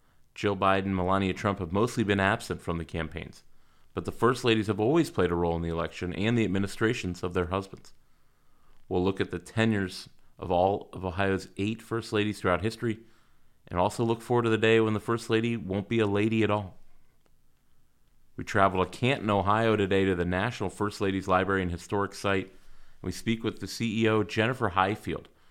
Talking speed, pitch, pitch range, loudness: 195 wpm, 100 Hz, 95-110 Hz, -28 LUFS